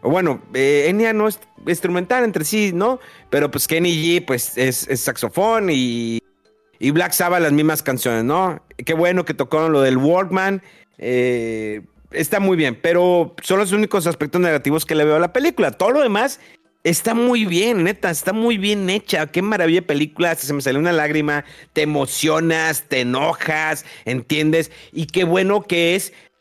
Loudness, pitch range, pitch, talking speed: -18 LUFS, 145-190 Hz, 165 Hz, 180 wpm